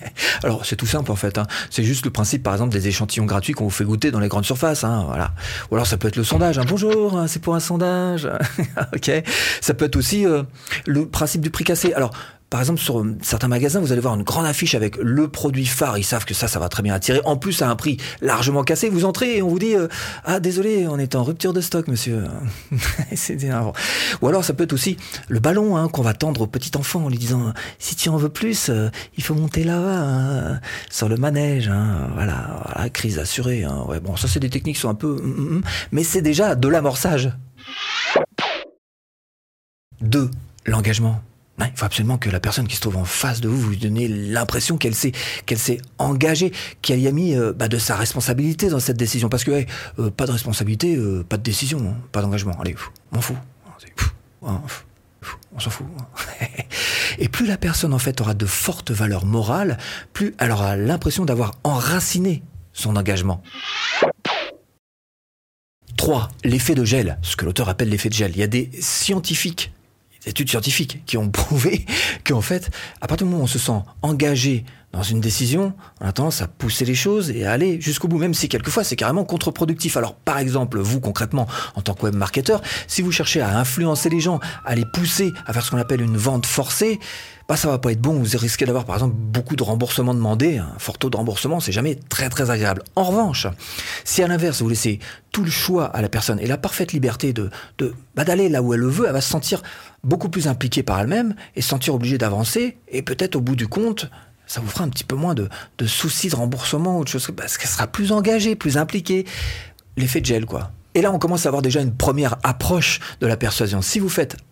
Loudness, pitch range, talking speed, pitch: -21 LUFS, 110-160 Hz, 220 wpm, 130 Hz